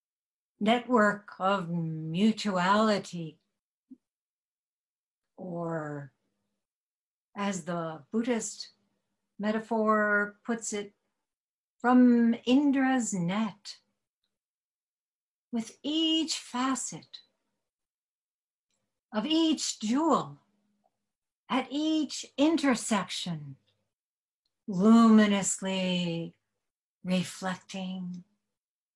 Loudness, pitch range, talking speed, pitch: -28 LUFS, 180-240 Hz, 50 wpm, 210 Hz